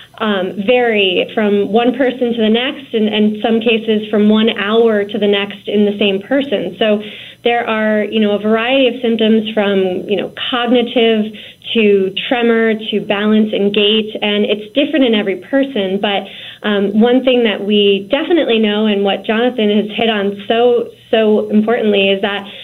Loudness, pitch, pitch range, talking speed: -14 LUFS, 215 Hz, 205-235 Hz, 175 wpm